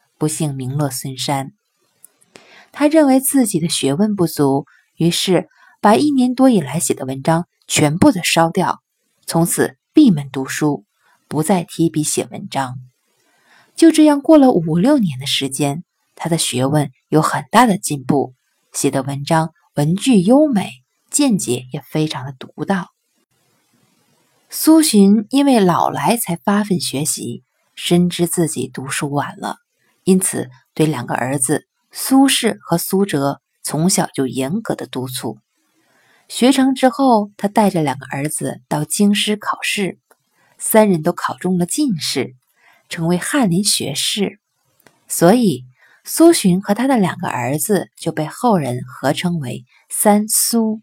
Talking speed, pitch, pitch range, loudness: 205 characters per minute, 175 Hz, 145-215 Hz, -16 LUFS